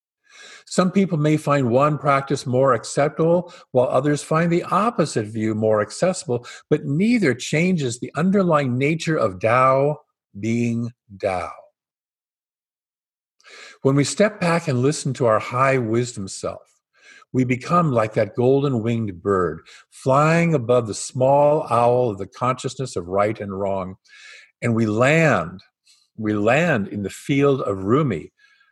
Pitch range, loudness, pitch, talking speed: 115-160 Hz, -20 LUFS, 135 Hz, 140 wpm